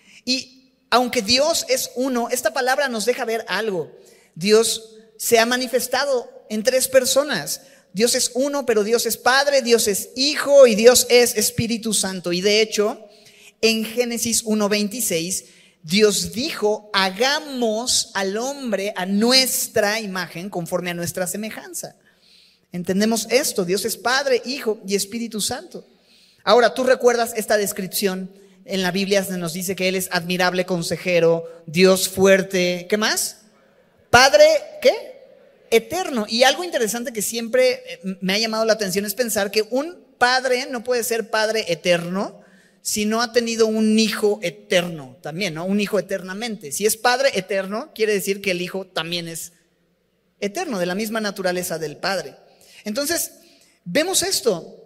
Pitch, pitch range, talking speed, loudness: 220 Hz, 190-250 Hz, 150 wpm, -20 LUFS